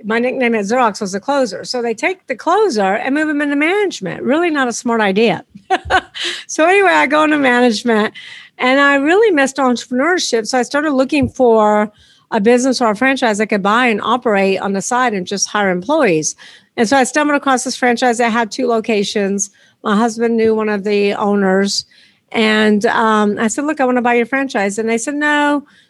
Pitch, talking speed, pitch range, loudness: 240 Hz, 205 wpm, 215-275 Hz, -14 LUFS